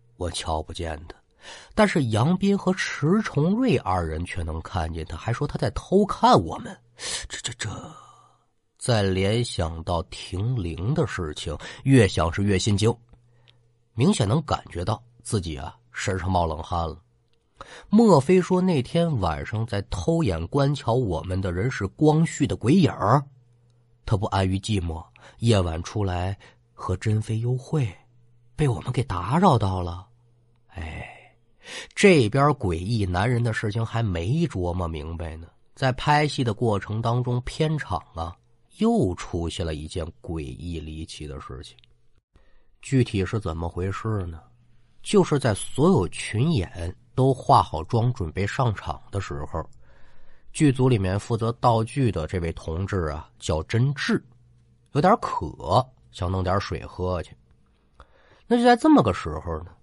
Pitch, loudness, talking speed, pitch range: 115 Hz, -24 LUFS, 210 characters per minute, 90-130 Hz